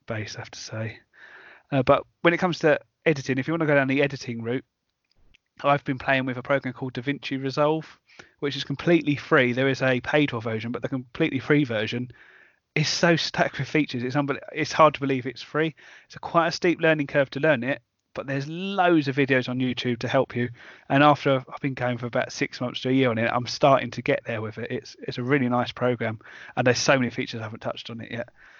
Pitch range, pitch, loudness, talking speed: 125-145 Hz, 135 Hz, -24 LUFS, 240 wpm